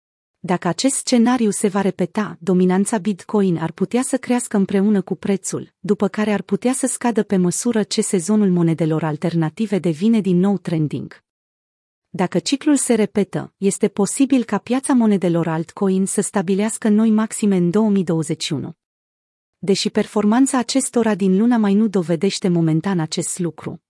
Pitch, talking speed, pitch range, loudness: 200 Hz, 145 wpm, 175-215 Hz, -19 LUFS